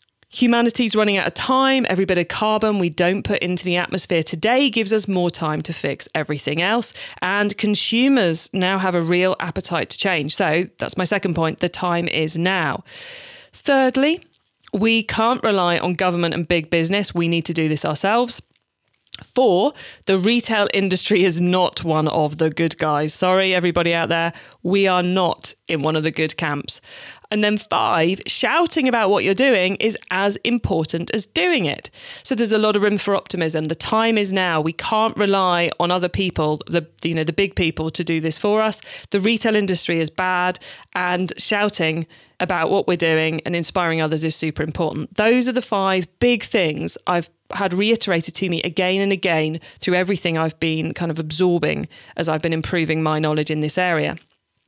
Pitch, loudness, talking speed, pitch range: 180 Hz, -19 LUFS, 190 wpm, 165-210 Hz